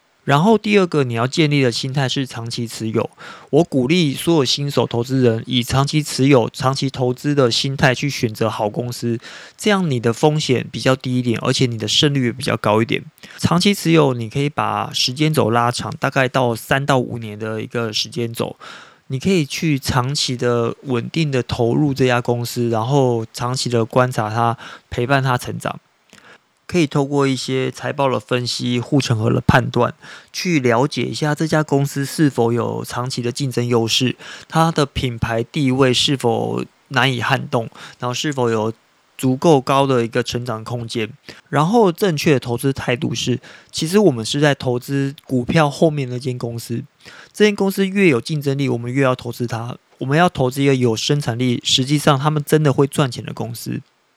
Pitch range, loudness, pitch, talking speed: 120-145 Hz, -18 LUFS, 130 Hz, 280 characters per minute